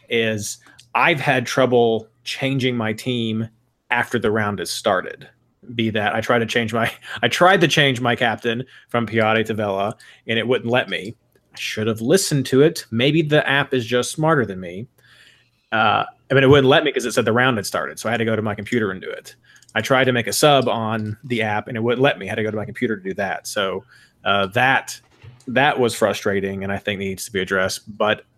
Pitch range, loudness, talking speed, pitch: 110-130 Hz, -19 LUFS, 235 wpm, 115 Hz